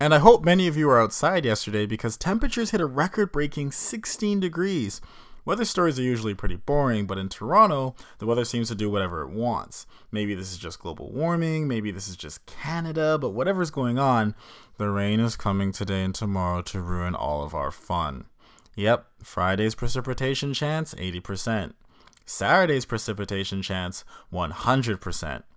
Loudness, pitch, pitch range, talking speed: -25 LUFS, 115 Hz, 95-150 Hz, 165 wpm